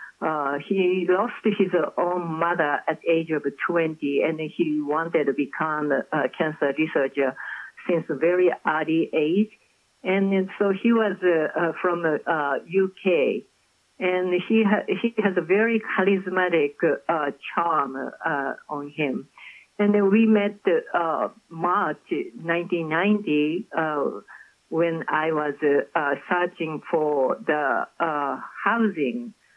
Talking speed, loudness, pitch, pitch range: 140 wpm, -24 LUFS, 175 Hz, 155-200 Hz